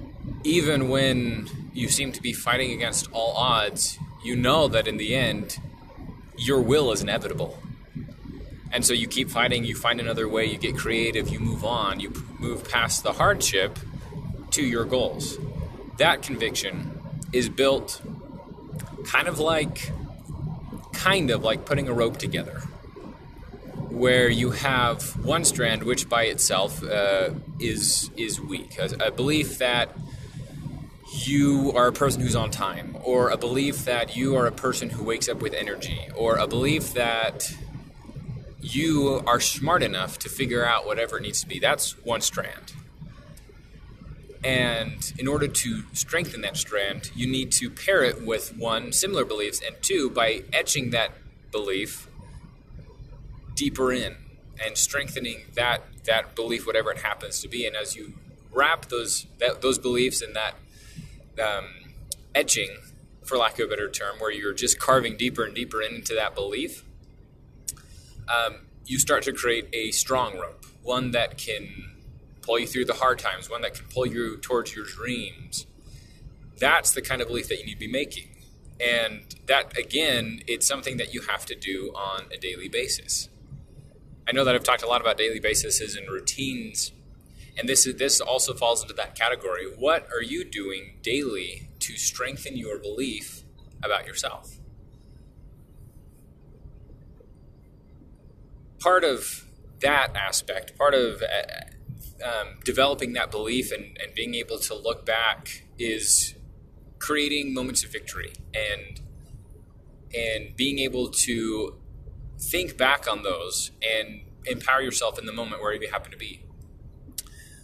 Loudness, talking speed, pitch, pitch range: -25 LUFS, 155 wpm, 125 Hz, 115-140 Hz